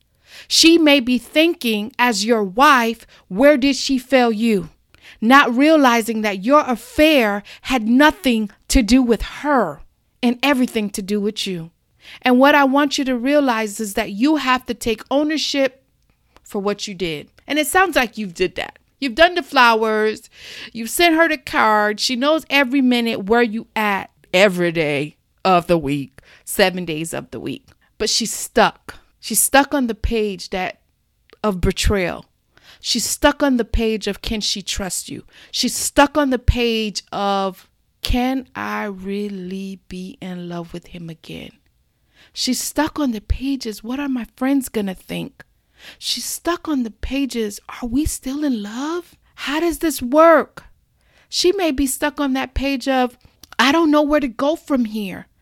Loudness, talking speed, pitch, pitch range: -18 LUFS, 170 wpm, 245 Hz, 210-280 Hz